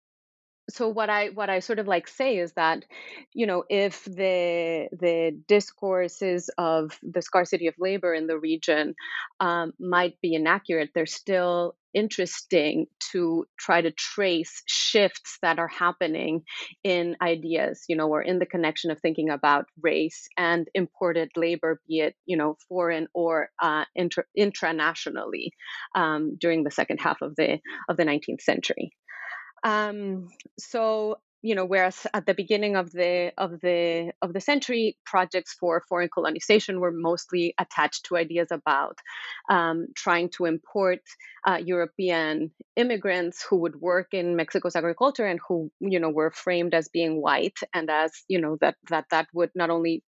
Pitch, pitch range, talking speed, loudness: 175 Hz, 165-190 Hz, 160 wpm, -26 LUFS